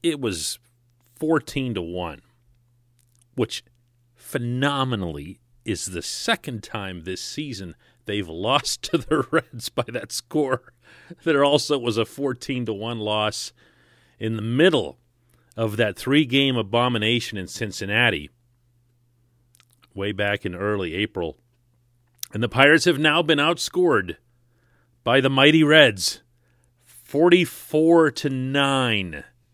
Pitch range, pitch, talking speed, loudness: 115-140 Hz, 120 Hz, 120 wpm, -22 LUFS